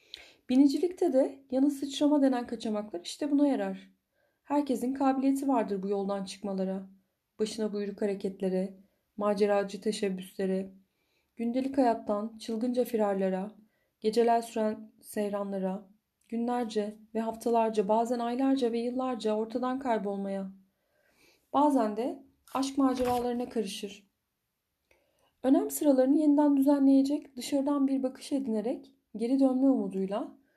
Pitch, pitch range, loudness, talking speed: 230 Hz, 205-270 Hz, -30 LUFS, 100 wpm